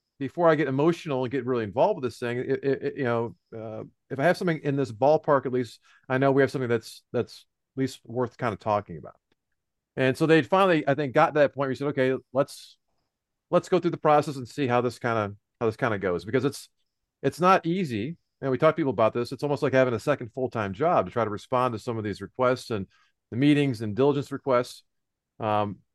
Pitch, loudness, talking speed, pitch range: 130 Hz, -26 LUFS, 245 wpm, 115-145 Hz